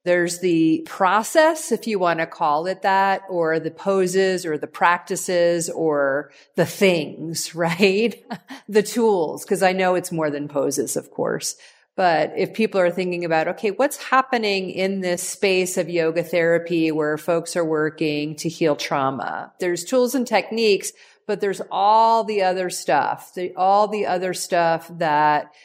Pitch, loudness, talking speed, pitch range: 180 Hz, -21 LUFS, 160 wpm, 165-200 Hz